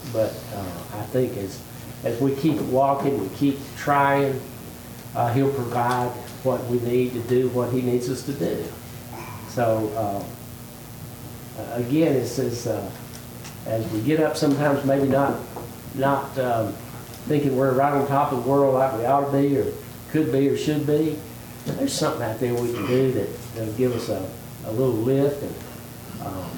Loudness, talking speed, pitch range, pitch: -23 LUFS, 175 wpm, 120-140 Hz, 125 Hz